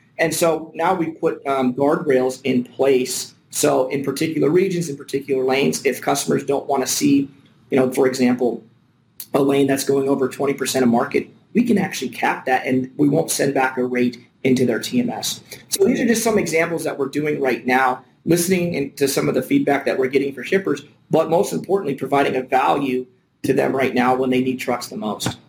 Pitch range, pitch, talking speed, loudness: 130-155 Hz, 135 Hz, 205 wpm, -20 LUFS